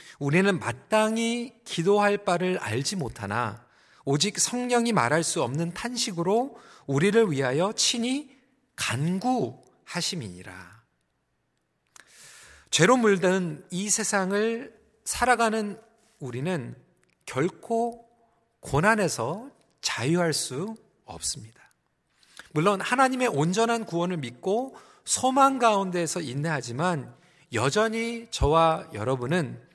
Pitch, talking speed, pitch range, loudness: 185 Hz, 220 characters per minute, 145-230 Hz, -26 LUFS